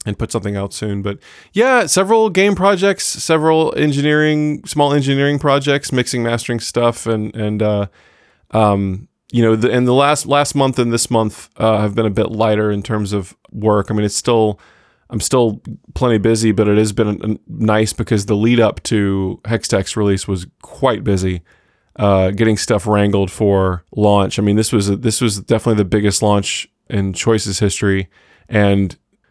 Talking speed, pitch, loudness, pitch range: 180 wpm, 110 Hz, -16 LUFS, 100-125 Hz